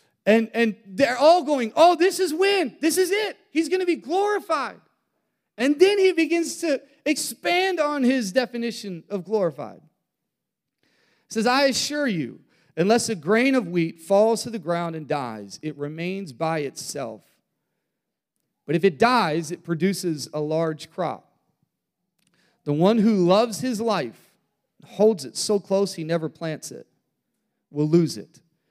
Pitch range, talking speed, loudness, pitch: 170-280 Hz, 155 wpm, -22 LUFS, 215 Hz